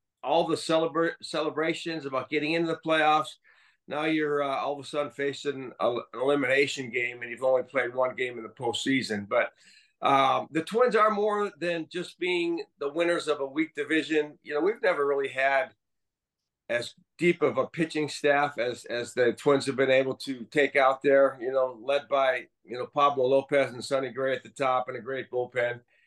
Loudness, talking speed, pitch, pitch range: -27 LUFS, 200 wpm, 140 Hz, 130-160 Hz